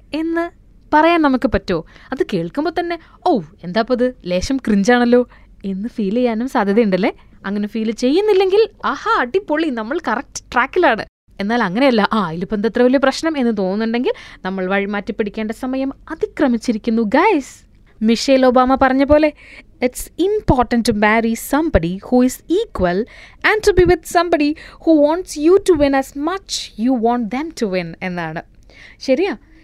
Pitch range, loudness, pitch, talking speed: 220-320 Hz, -17 LUFS, 255 Hz, 110 wpm